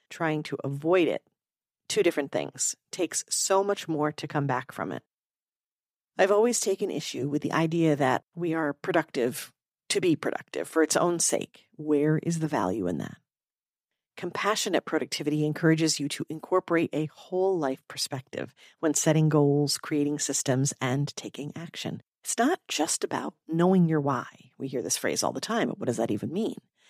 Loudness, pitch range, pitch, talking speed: -27 LUFS, 145-175 Hz, 155 Hz, 175 wpm